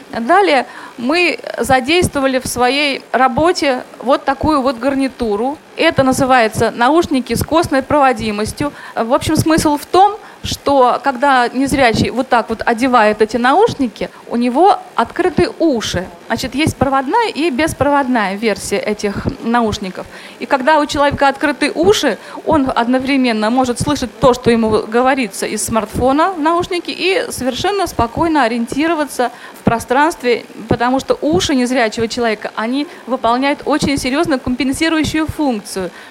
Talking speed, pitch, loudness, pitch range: 130 wpm, 265 Hz, -15 LUFS, 235-300 Hz